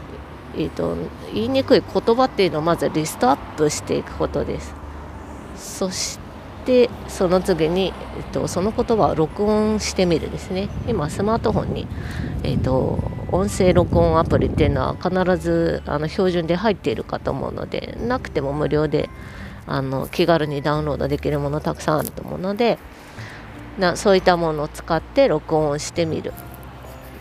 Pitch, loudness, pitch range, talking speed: 155 Hz, -21 LUFS, 115-185 Hz, 335 characters per minute